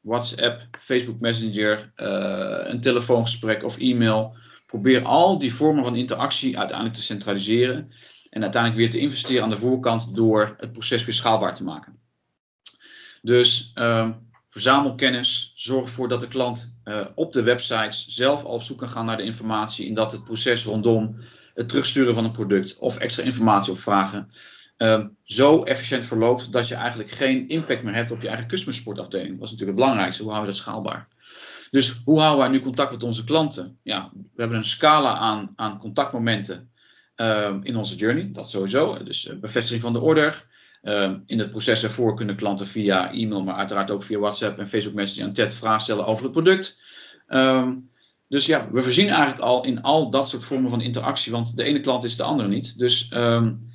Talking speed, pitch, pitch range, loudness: 190 wpm, 115 Hz, 110-130 Hz, -22 LUFS